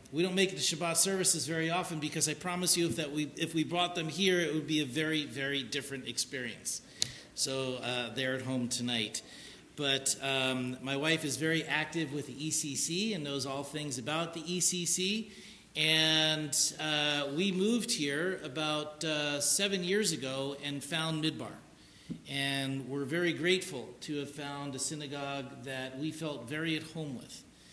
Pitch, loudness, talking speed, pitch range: 155 Hz, -32 LUFS, 175 wpm, 140-165 Hz